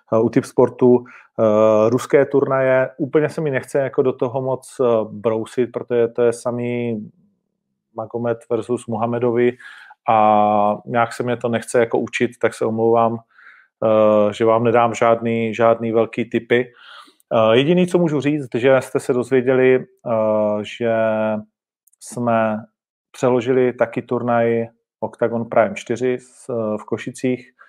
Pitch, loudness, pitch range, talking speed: 120 Hz, -18 LUFS, 115-130 Hz, 130 wpm